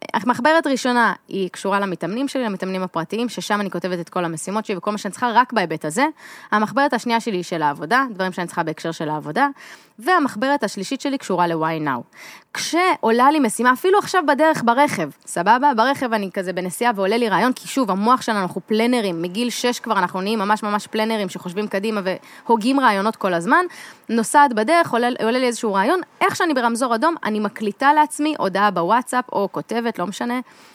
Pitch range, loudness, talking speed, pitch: 195-265 Hz, -20 LUFS, 185 wpm, 225 Hz